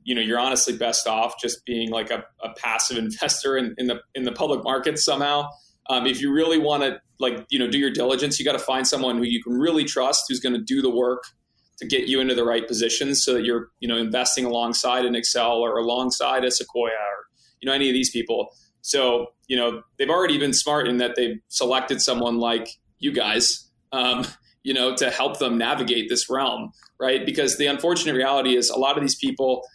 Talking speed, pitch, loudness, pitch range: 225 wpm, 125 Hz, -22 LUFS, 120-130 Hz